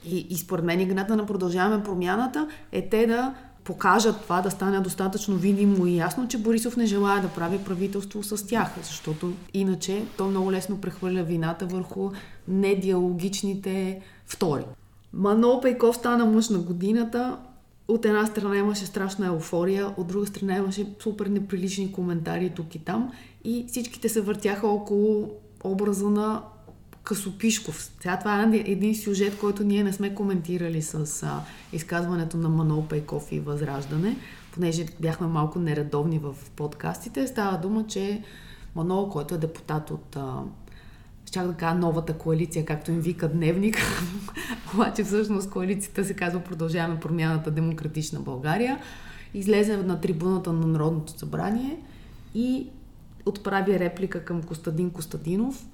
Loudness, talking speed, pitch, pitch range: -26 LUFS, 140 wpm, 190 Hz, 170-205 Hz